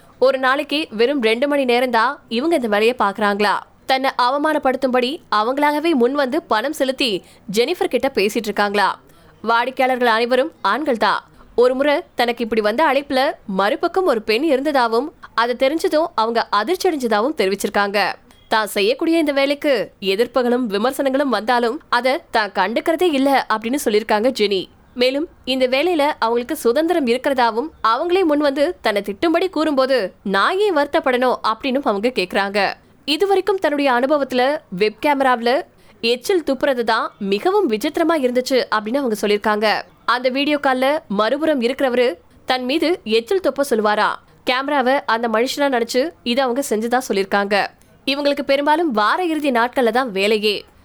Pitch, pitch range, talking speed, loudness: 255 Hz, 225-290 Hz, 125 wpm, -18 LUFS